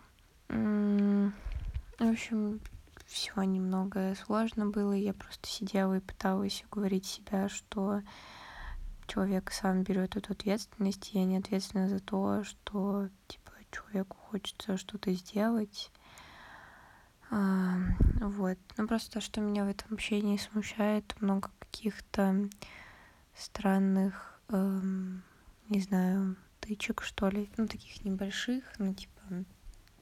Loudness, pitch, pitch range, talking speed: -34 LUFS, 200 Hz, 190-210 Hz, 115 wpm